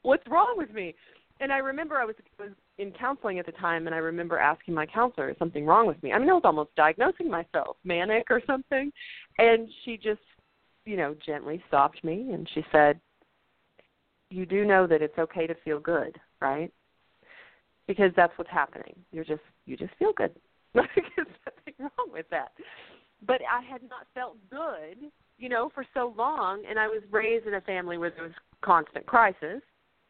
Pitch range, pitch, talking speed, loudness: 165-260 Hz, 210 Hz, 185 wpm, -27 LUFS